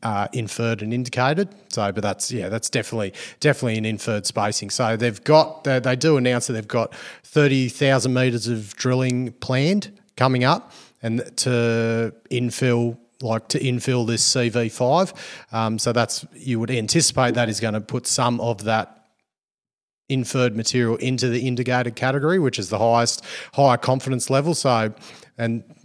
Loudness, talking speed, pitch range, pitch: -21 LUFS, 165 wpm, 115-130 Hz, 125 Hz